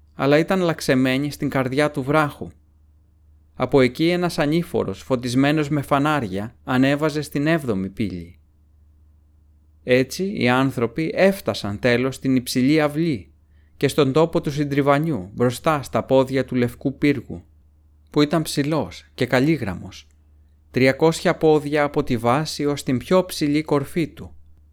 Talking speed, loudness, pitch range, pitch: 130 wpm, -21 LUFS, 95-150 Hz, 130 Hz